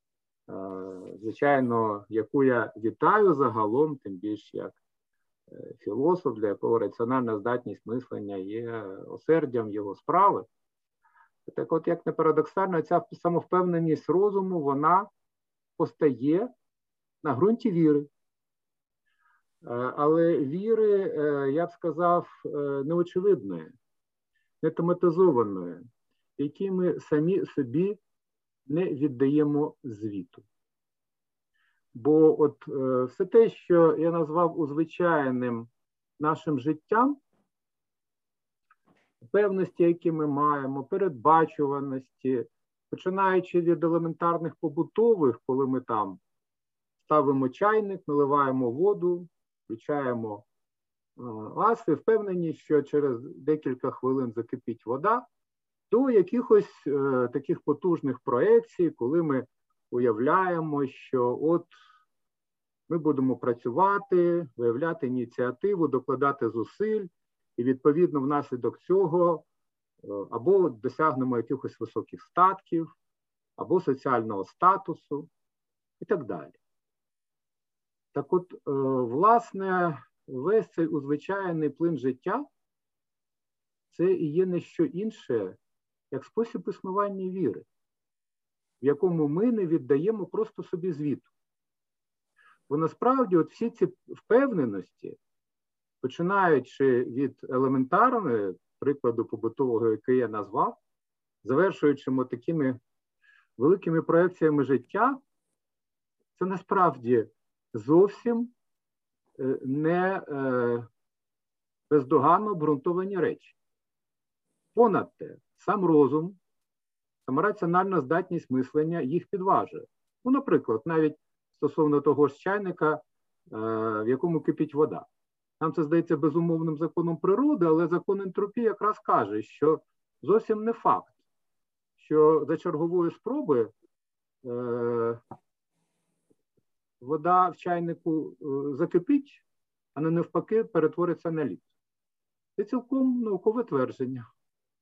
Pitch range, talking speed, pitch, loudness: 135-185 Hz, 90 wpm, 160 Hz, -27 LUFS